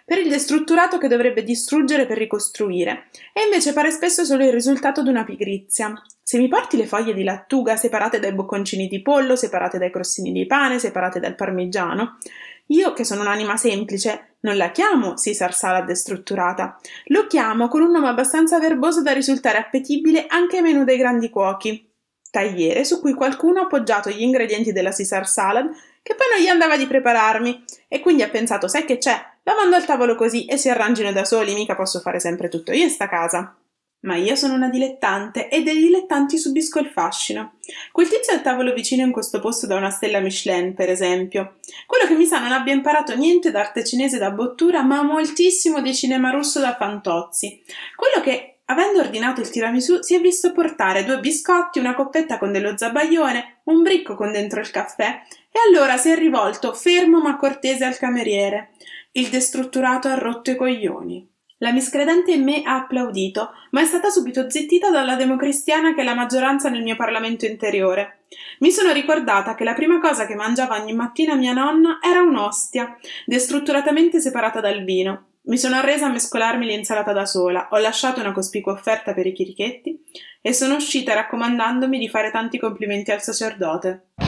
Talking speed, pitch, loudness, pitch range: 185 wpm, 255 Hz, -19 LUFS, 210-300 Hz